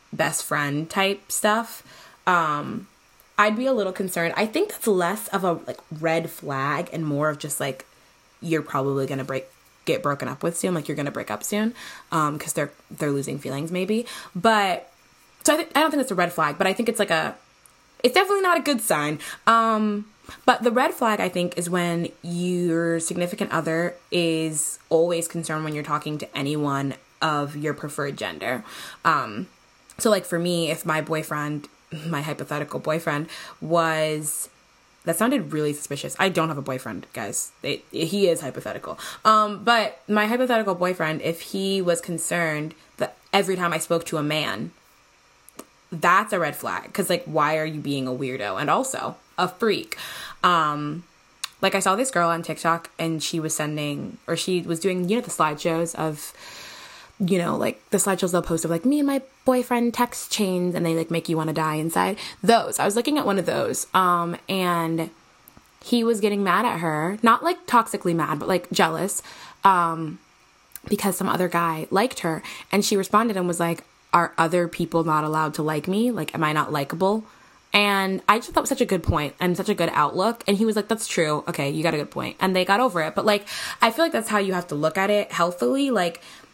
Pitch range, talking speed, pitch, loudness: 155-205 Hz, 205 wpm, 170 Hz, -23 LUFS